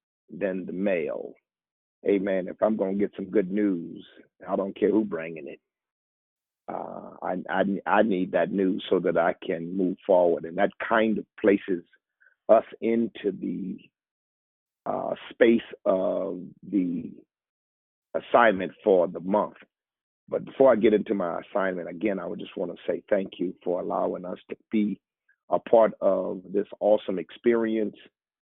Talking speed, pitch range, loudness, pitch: 155 wpm, 90-105 Hz, -26 LUFS, 95 Hz